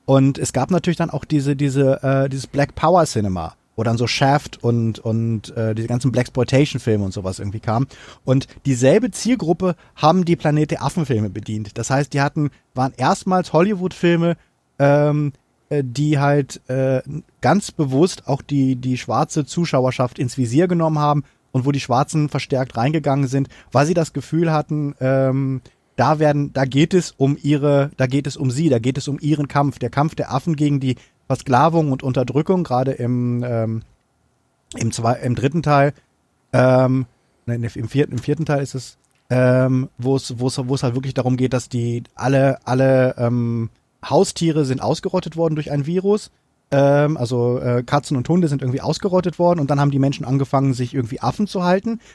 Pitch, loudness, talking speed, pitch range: 135 Hz, -19 LUFS, 180 wpm, 125-150 Hz